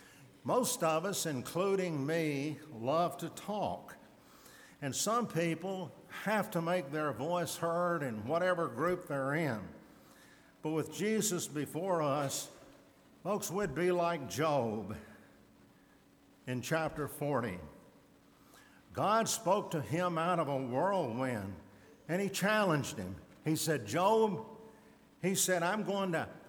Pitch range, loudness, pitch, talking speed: 145-185 Hz, -34 LUFS, 165 Hz, 125 wpm